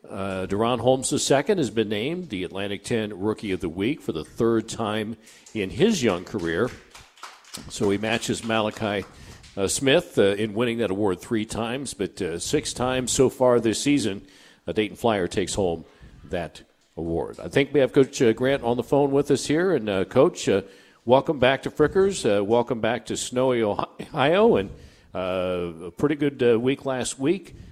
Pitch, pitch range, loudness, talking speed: 115 Hz, 100-130 Hz, -24 LUFS, 190 wpm